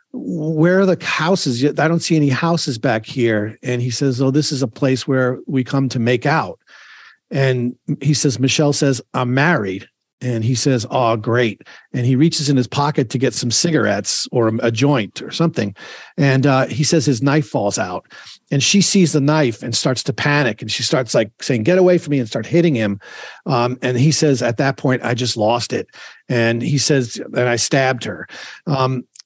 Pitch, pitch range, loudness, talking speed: 135 Hz, 125-150 Hz, -17 LUFS, 205 wpm